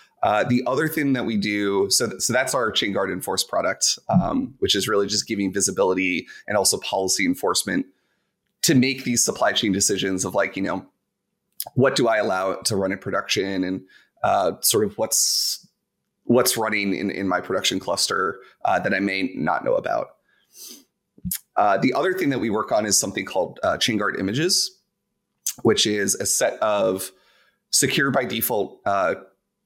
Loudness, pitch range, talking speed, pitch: -21 LUFS, 95-125 Hz, 180 wpm, 105 Hz